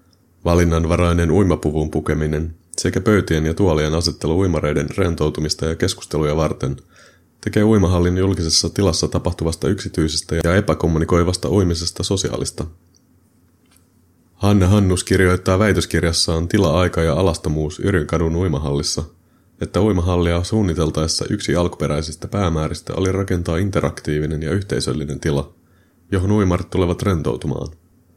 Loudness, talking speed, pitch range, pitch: -19 LUFS, 100 wpm, 80-95 Hz, 85 Hz